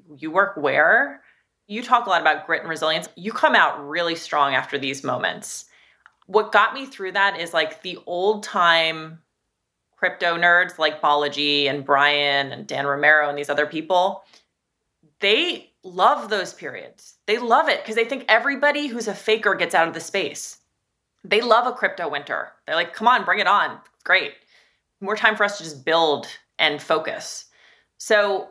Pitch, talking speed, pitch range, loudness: 175 Hz, 175 wpm, 155-215 Hz, -20 LUFS